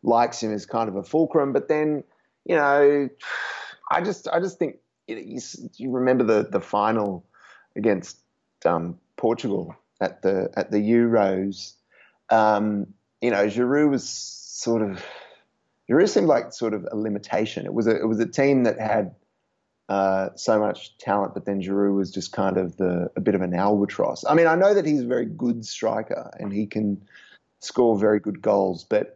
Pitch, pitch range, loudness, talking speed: 110 Hz, 100-125 Hz, -23 LUFS, 185 wpm